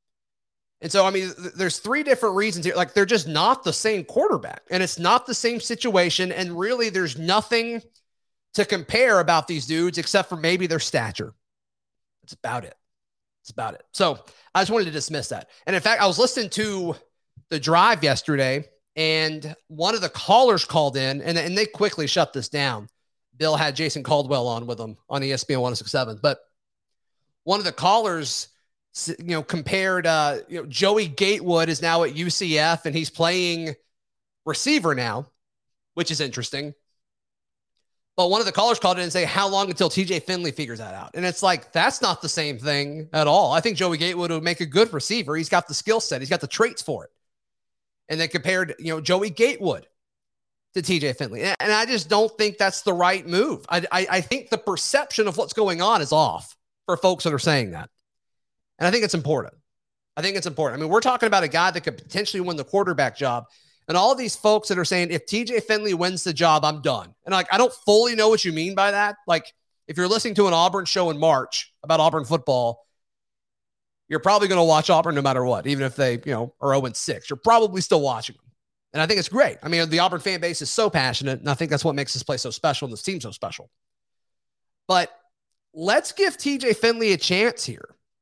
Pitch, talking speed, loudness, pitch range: 175 Hz, 215 wpm, -22 LUFS, 150-200 Hz